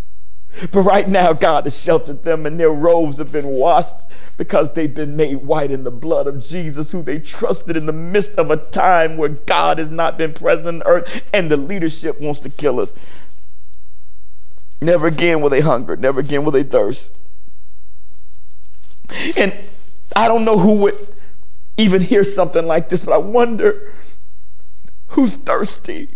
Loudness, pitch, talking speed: -16 LUFS, 155 Hz, 165 wpm